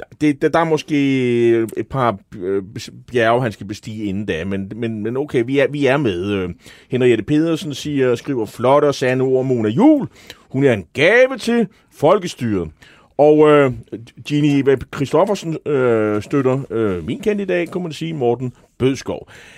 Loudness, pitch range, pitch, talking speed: -17 LUFS, 115-150 Hz, 130 Hz, 160 wpm